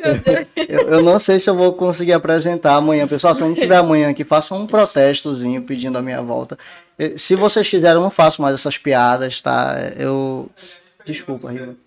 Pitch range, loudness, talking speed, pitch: 135-180 Hz, -15 LUFS, 180 wpm, 155 Hz